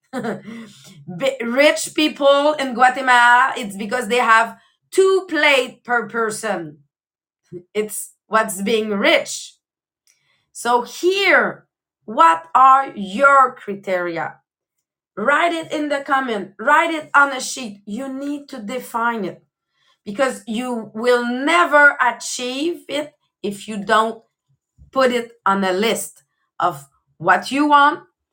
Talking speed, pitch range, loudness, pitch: 115 wpm, 215-285 Hz, -17 LUFS, 245 Hz